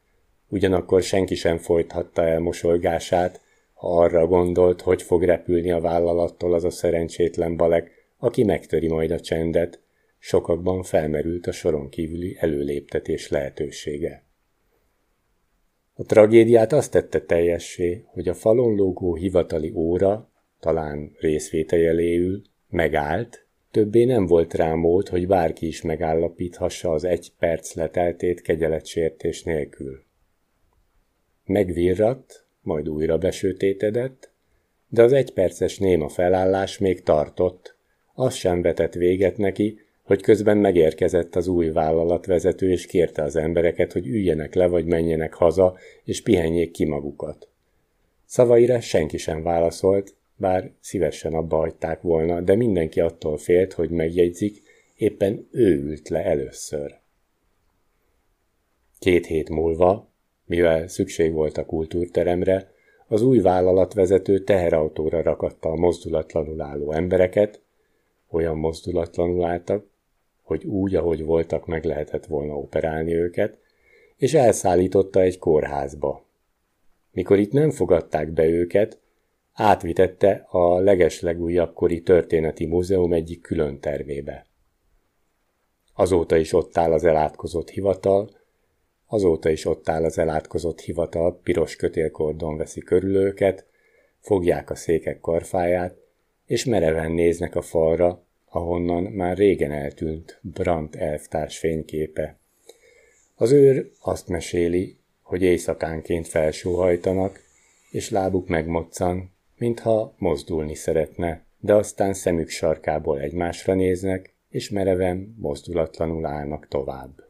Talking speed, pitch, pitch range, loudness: 115 wpm, 90 Hz, 80-95 Hz, -22 LUFS